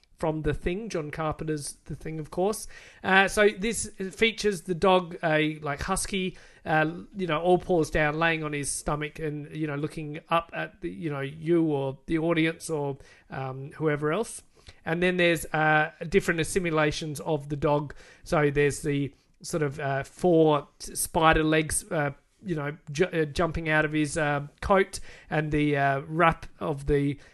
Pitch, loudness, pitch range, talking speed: 155 Hz, -27 LUFS, 150-175 Hz, 175 wpm